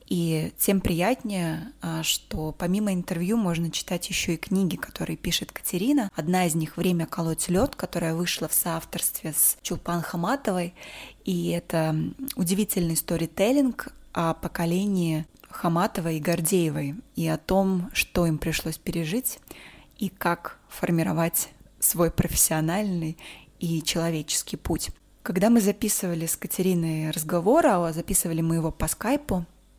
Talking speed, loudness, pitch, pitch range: 125 wpm, -26 LUFS, 175 Hz, 165-190 Hz